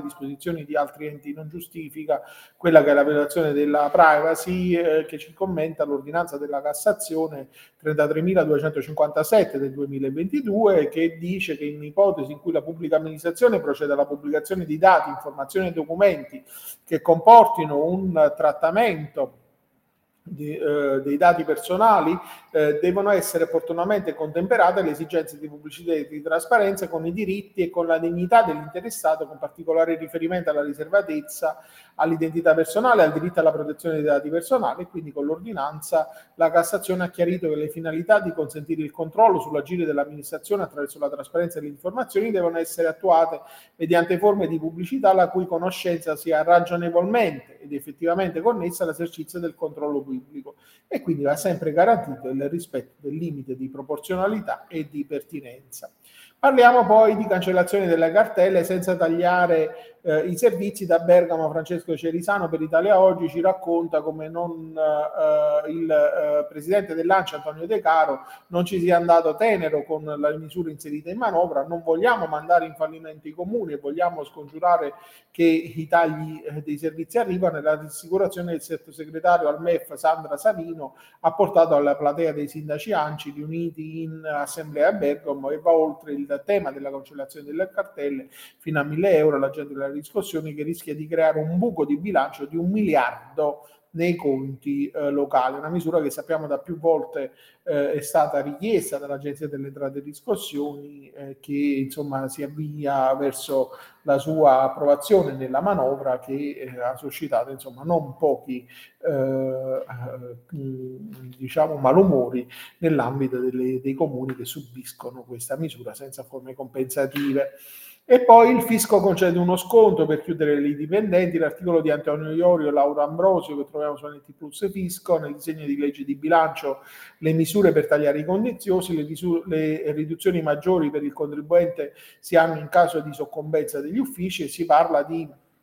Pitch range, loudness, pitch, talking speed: 145-180 Hz, -22 LUFS, 160 Hz, 155 wpm